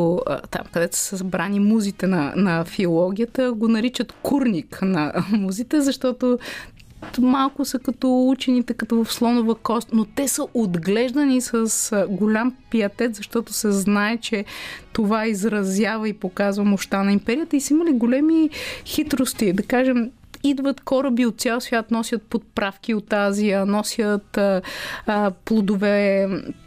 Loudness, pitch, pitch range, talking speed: -21 LUFS, 225 Hz, 200-250 Hz, 135 wpm